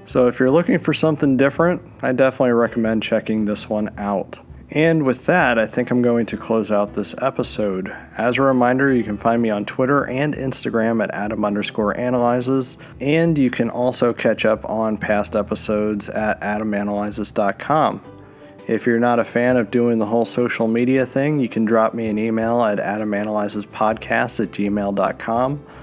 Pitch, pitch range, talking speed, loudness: 115 Hz, 105-130 Hz, 170 wpm, -19 LUFS